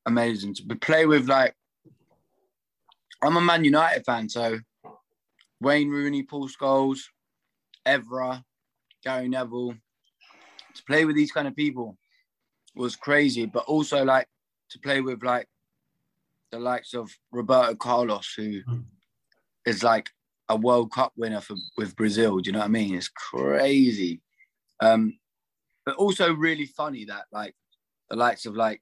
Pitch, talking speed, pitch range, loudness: 125 Hz, 140 wpm, 115-145 Hz, -24 LUFS